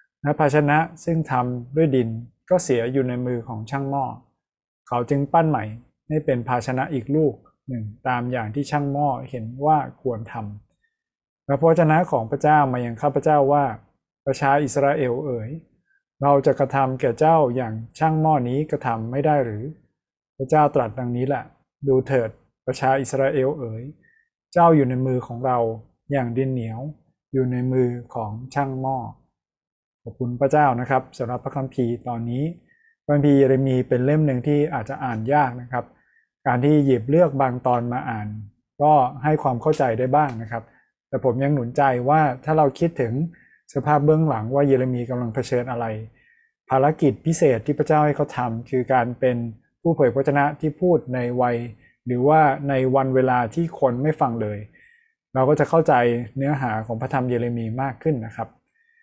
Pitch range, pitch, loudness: 125-150 Hz, 135 Hz, -21 LUFS